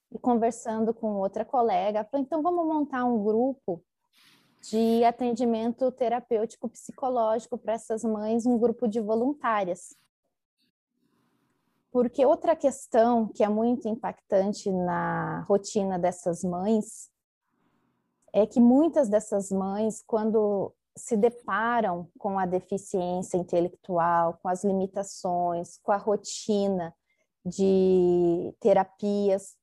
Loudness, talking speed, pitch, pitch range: -27 LUFS, 105 wpm, 215 Hz, 190-240 Hz